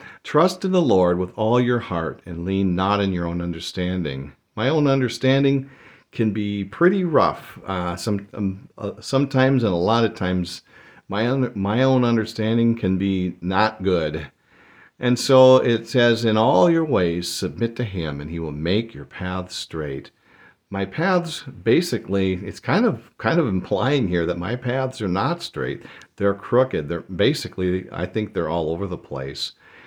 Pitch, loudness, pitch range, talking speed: 105 Hz, -21 LUFS, 90-125 Hz, 175 wpm